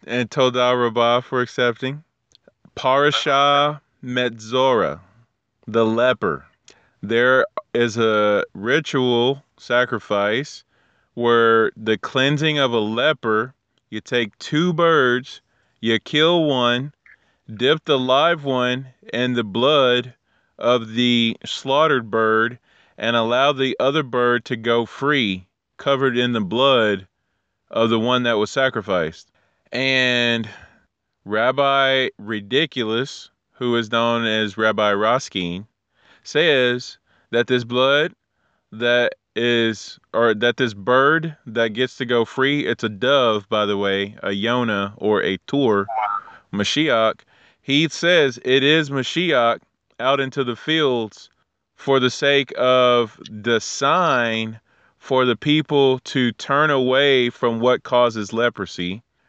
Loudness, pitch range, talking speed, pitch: -19 LUFS, 110-130 Hz, 120 wpm, 120 Hz